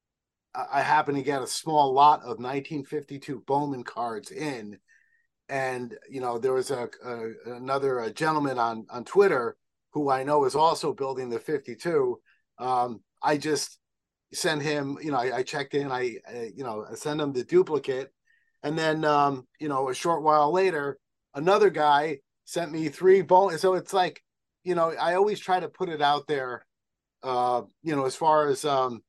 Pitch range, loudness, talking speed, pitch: 130-170 Hz, -26 LUFS, 180 wpm, 145 Hz